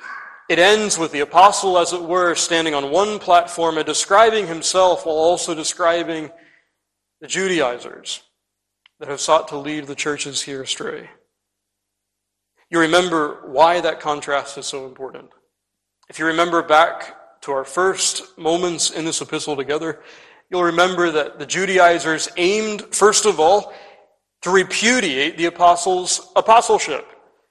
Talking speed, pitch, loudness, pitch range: 135 wpm, 170 Hz, -17 LUFS, 150-190 Hz